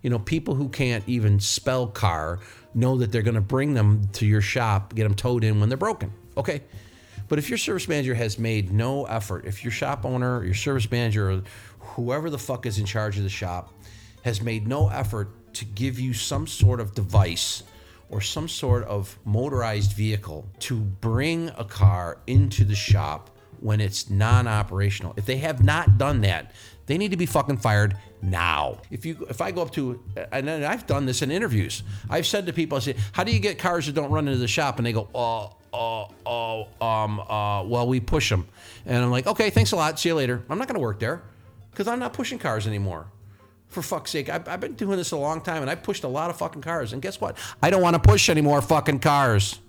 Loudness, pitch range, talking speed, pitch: -24 LUFS, 100-140 Hz, 230 wpm, 115 Hz